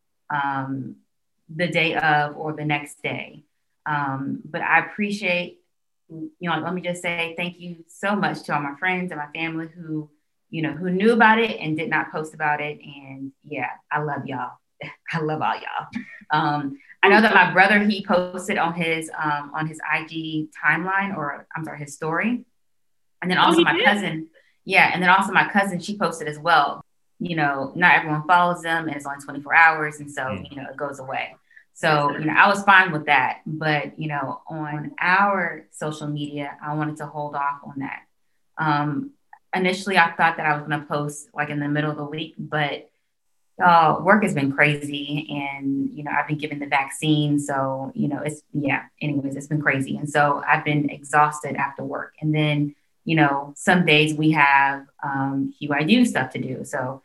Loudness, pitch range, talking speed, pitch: -21 LUFS, 145-170 Hz, 195 wpm, 150 Hz